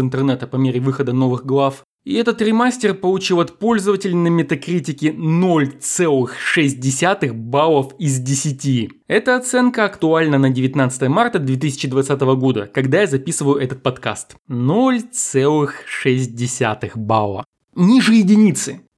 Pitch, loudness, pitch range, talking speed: 140 Hz, -17 LUFS, 130-185 Hz, 110 wpm